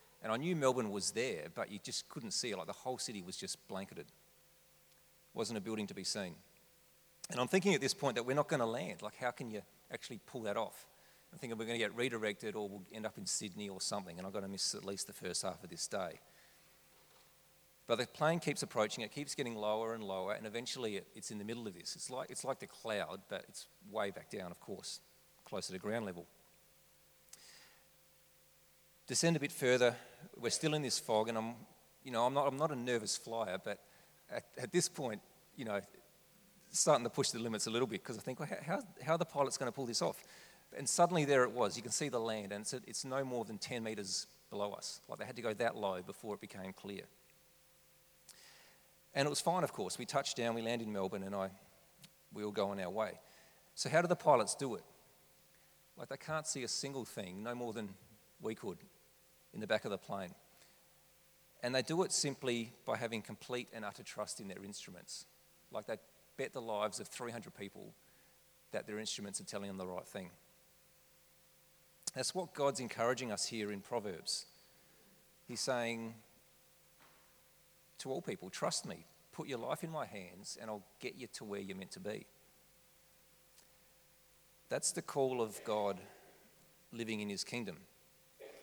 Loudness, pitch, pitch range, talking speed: -39 LUFS, 115 Hz, 105-140 Hz, 210 wpm